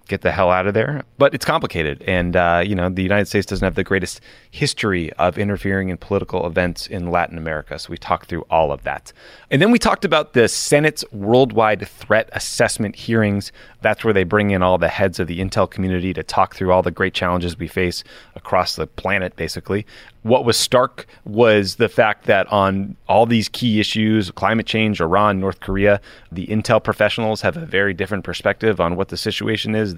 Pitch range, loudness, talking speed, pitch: 90-110 Hz, -18 LUFS, 205 wpm, 100 Hz